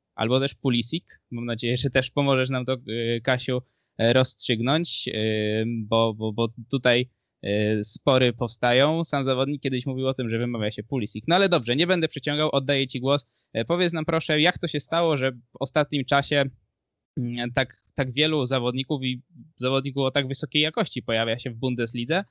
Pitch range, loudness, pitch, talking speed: 120-145 Hz, -24 LUFS, 130 Hz, 165 wpm